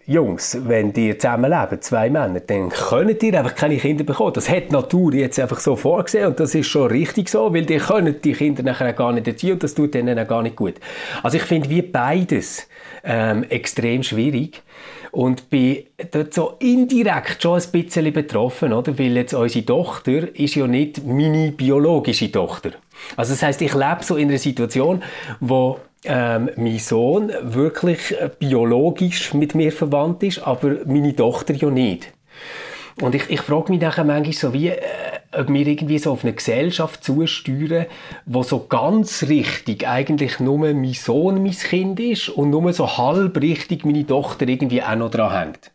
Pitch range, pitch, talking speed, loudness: 130-165 Hz, 150 Hz, 180 wpm, -19 LUFS